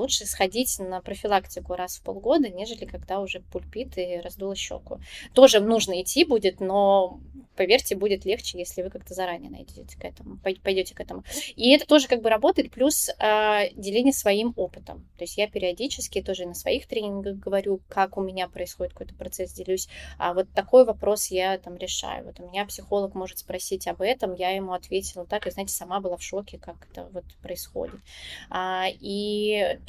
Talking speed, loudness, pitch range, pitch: 180 wpm, -25 LUFS, 185-215 Hz, 195 Hz